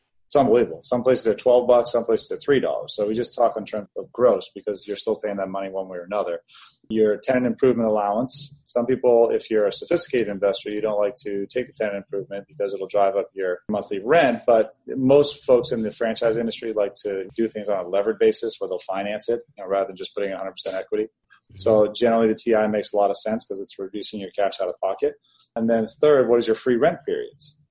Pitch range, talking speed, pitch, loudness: 105-150 Hz, 235 wpm, 115 Hz, -22 LUFS